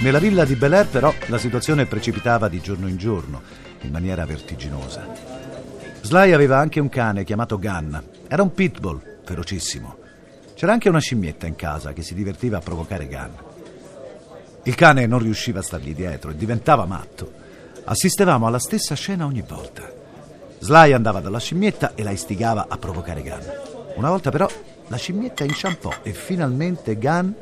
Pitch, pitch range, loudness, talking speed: 115 Hz, 95-150 Hz, -20 LUFS, 160 wpm